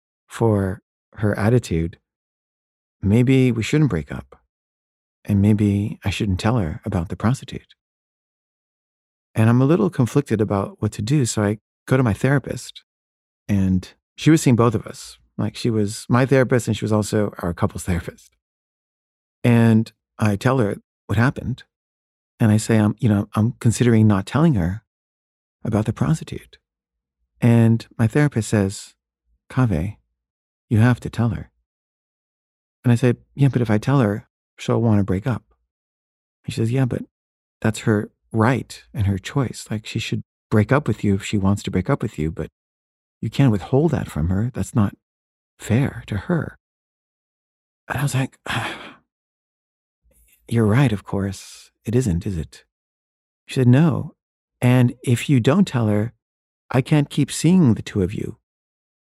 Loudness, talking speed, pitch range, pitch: -20 LUFS, 165 wpm, 85-125 Hz, 105 Hz